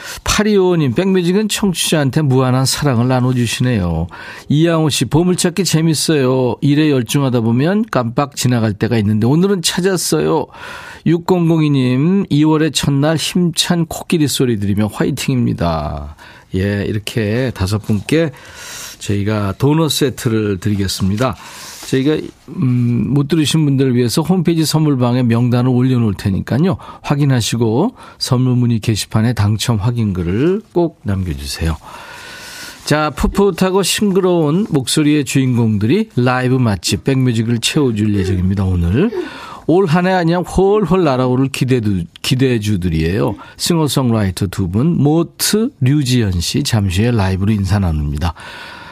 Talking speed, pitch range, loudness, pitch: 305 characters per minute, 110-165 Hz, -15 LUFS, 130 Hz